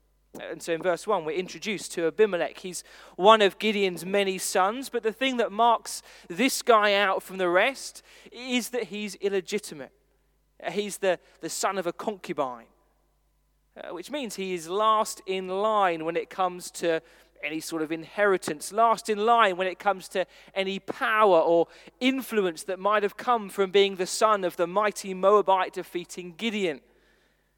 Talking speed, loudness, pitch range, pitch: 170 wpm, -26 LUFS, 175-215 Hz, 195 Hz